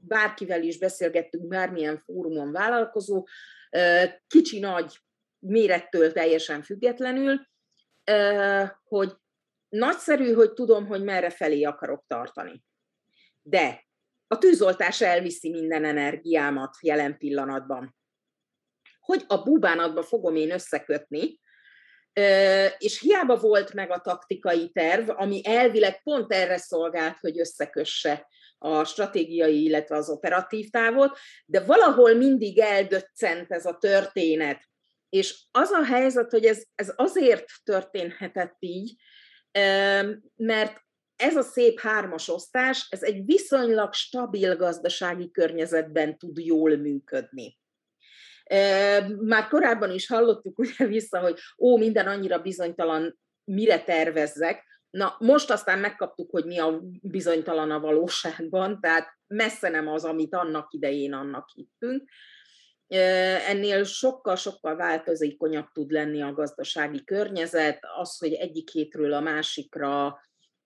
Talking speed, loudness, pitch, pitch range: 110 wpm, -24 LUFS, 185 Hz, 160-220 Hz